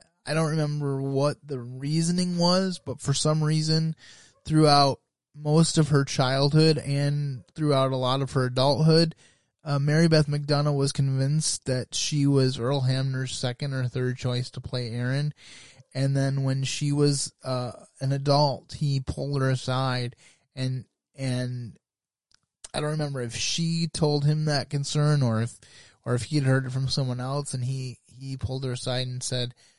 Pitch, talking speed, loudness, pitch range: 135 Hz, 165 wpm, -25 LUFS, 130-150 Hz